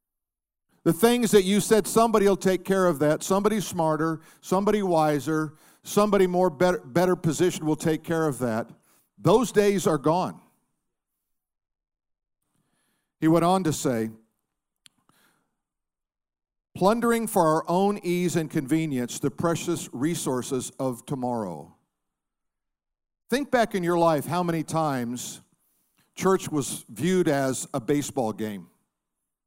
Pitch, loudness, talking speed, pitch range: 160 Hz, -24 LUFS, 120 wpm, 135-185 Hz